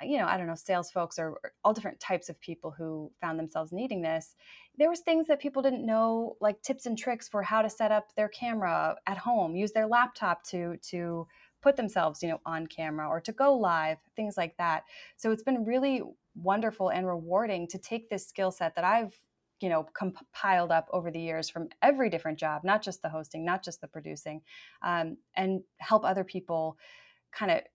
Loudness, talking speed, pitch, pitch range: -31 LUFS, 210 wpm, 190 Hz, 165-225 Hz